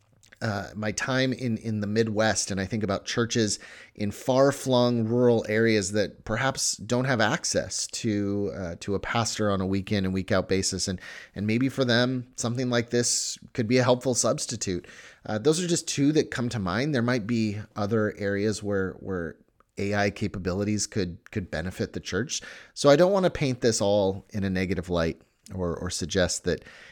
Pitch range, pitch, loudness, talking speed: 100-120 Hz, 110 Hz, -26 LUFS, 190 wpm